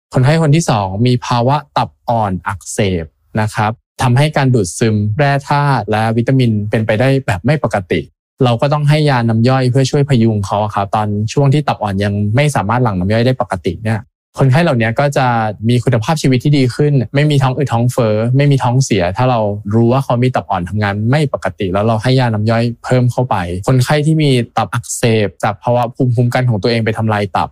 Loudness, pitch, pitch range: -14 LUFS, 120 Hz, 110-135 Hz